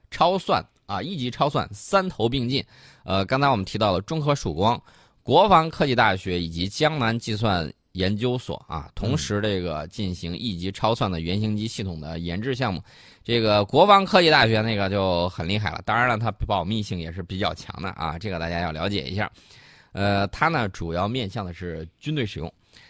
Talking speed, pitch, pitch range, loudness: 290 characters per minute, 100 Hz, 90-120 Hz, -23 LUFS